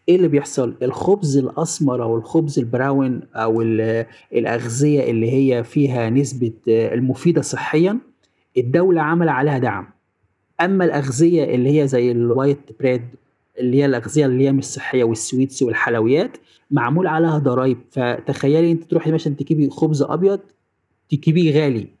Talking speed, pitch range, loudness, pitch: 130 wpm, 120-155 Hz, -18 LUFS, 135 Hz